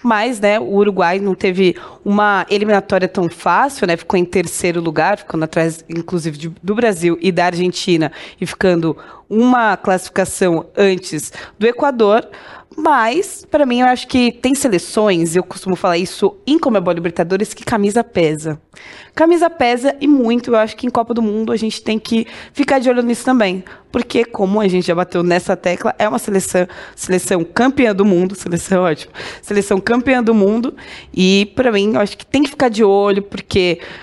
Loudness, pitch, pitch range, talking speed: -15 LUFS, 205 Hz, 180-235 Hz, 180 wpm